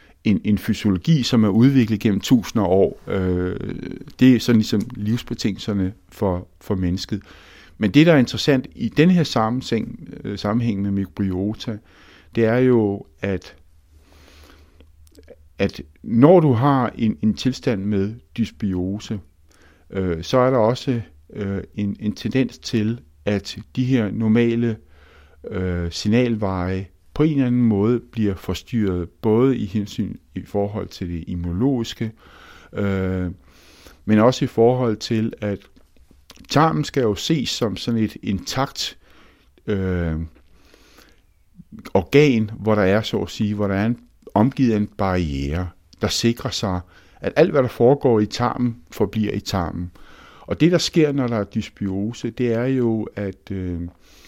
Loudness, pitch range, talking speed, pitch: -21 LUFS, 90-115 Hz, 145 wpm, 105 Hz